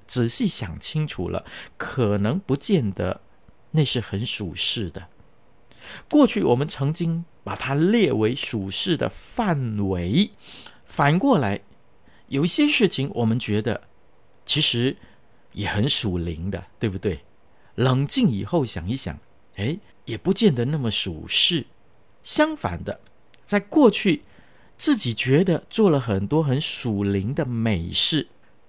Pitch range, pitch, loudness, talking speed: 100-155 Hz, 120 Hz, -23 LUFS, 190 characters per minute